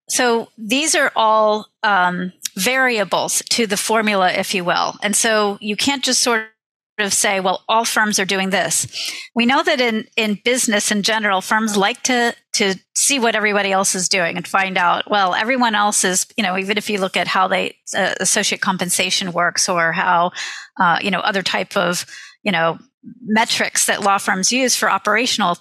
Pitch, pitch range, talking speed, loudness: 210 Hz, 190-230 Hz, 190 wpm, -17 LUFS